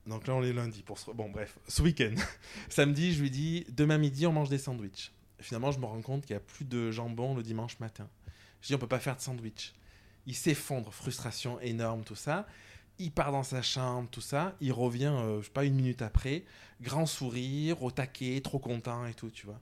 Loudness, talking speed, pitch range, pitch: -34 LUFS, 230 wpm, 110-140 Hz, 125 Hz